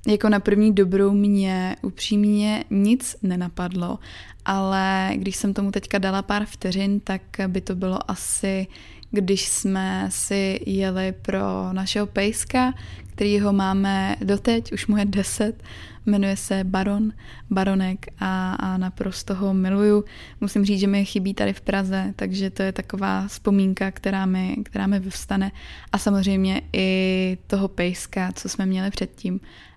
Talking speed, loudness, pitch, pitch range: 145 wpm, -23 LUFS, 195 Hz, 190-205 Hz